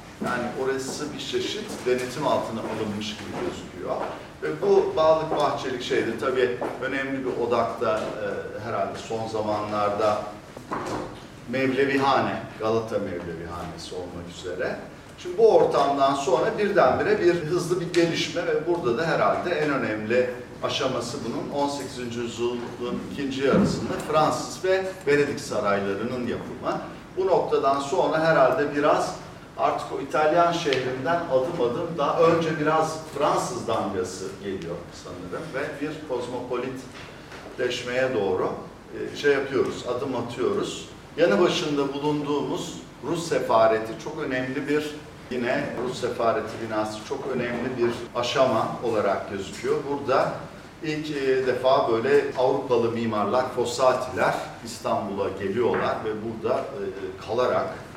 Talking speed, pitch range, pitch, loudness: 115 wpm, 115-155 Hz, 130 Hz, -25 LUFS